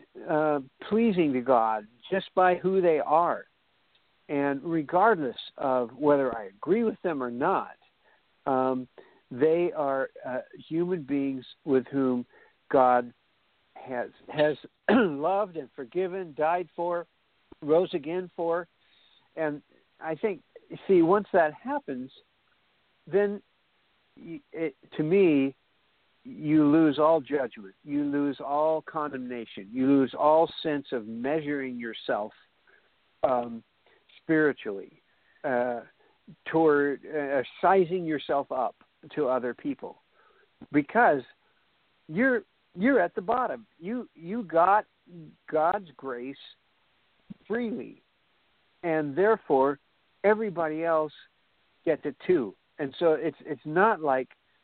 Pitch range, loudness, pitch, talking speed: 135-185 Hz, -27 LUFS, 155 Hz, 110 wpm